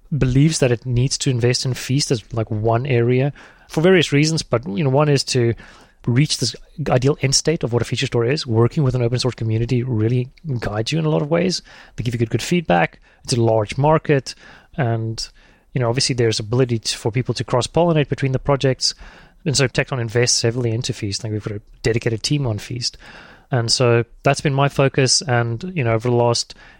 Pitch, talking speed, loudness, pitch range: 125 Hz, 220 wpm, -19 LUFS, 115-140 Hz